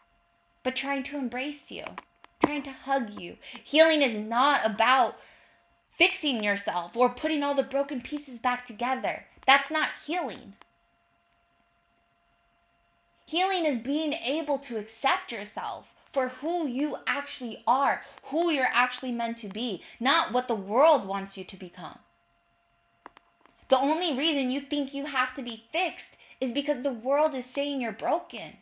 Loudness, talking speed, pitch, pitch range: -27 LUFS, 145 wpm, 270 Hz, 240-290 Hz